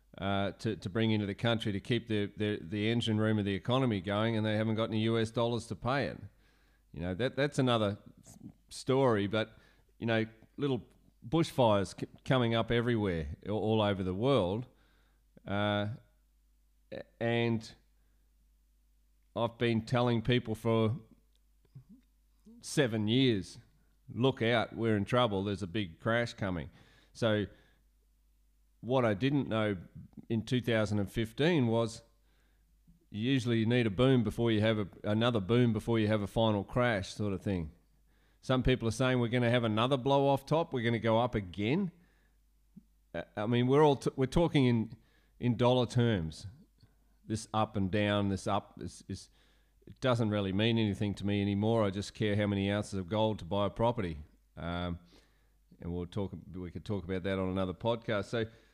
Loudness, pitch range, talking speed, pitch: -32 LUFS, 100-120 Hz, 170 wpm, 110 Hz